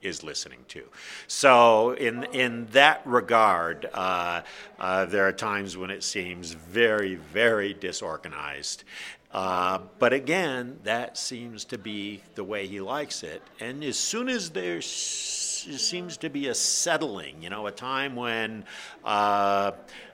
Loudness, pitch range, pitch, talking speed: -26 LUFS, 100-135 Hz, 110 Hz, 145 wpm